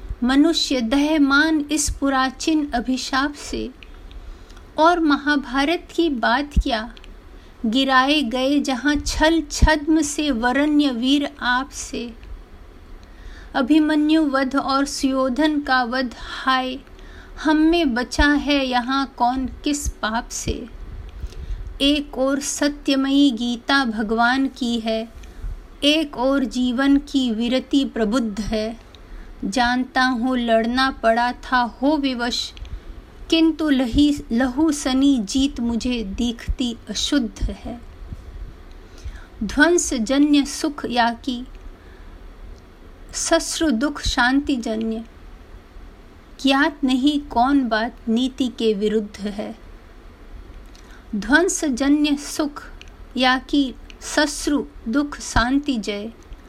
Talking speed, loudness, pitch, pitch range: 95 wpm, -20 LUFS, 260 Hz, 225-290 Hz